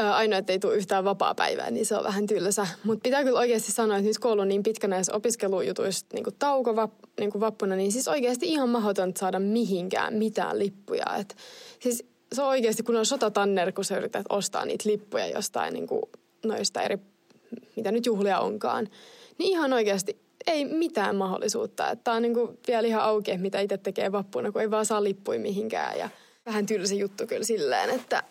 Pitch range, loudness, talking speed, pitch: 200-240 Hz, -27 LUFS, 190 wpm, 215 Hz